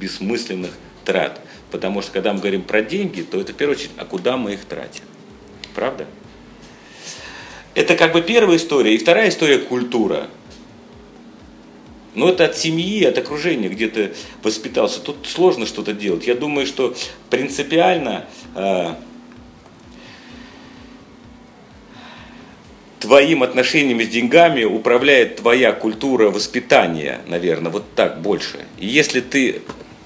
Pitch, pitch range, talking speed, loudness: 125 Hz, 105-160 Hz, 125 wpm, -17 LUFS